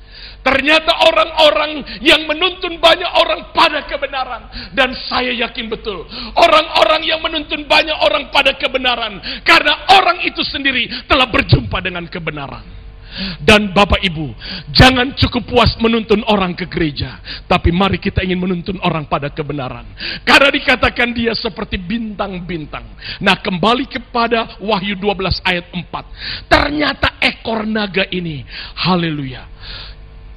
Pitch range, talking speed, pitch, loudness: 180-295 Hz, 120 wpm, 230 Hz, -14 LUFS